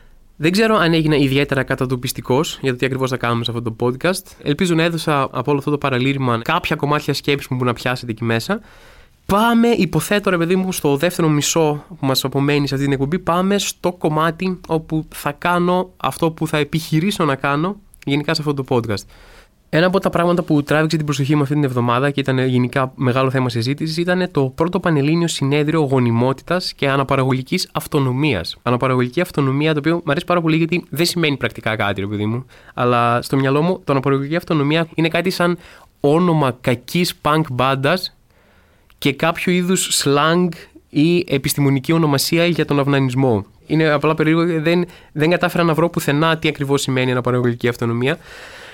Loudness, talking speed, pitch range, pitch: -18 LUFS, 180 wpm, 130-170 Hz, 150 Hz